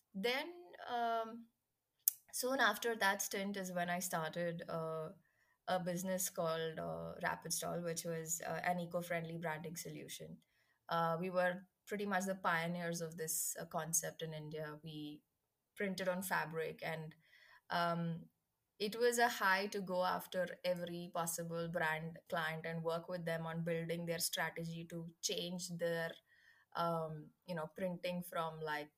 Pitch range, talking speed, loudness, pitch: 165-185 Hz, 145 wpm, -40 LUFS, 170 Hz